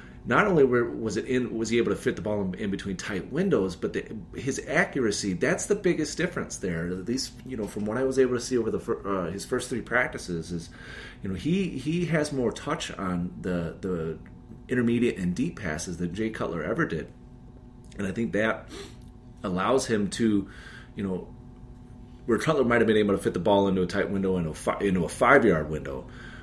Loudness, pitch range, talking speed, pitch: -27 LUFS, 90-125 Hz, 210 wpm, 110 Hz